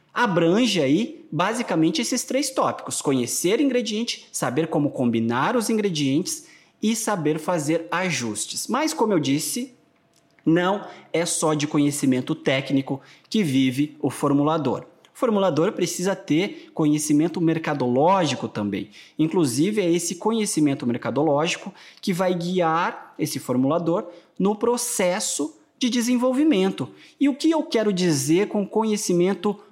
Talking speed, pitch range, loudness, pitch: 120 wpm, 150-225 Hz, -23 LUFS, 180 Hz